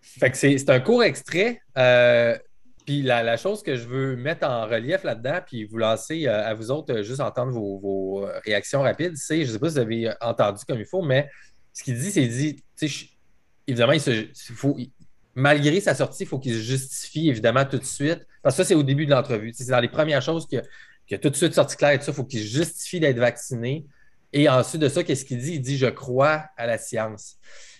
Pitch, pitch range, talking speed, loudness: 135 Hz, 120-150 Hz, 225 wpm, -23 LUFS